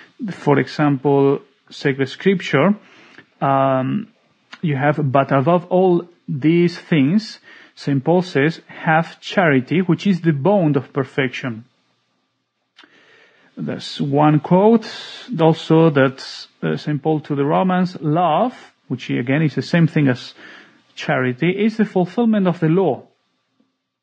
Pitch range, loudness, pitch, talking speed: 140-185 Hz, -18 LUFS, 160 Hz, 120 wpm